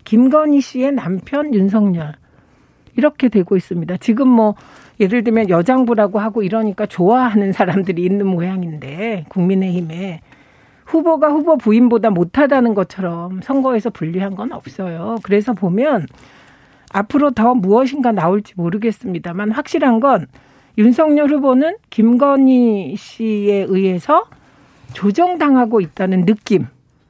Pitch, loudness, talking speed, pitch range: 215 Hz, -15 LUFS, 295 characters per minute, 185-255 Hz